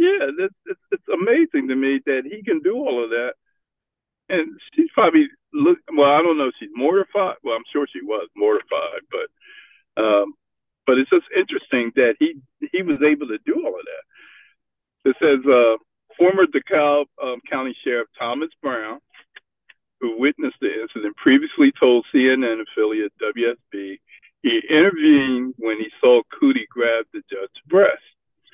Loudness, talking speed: -19 LUFS, 160 wpm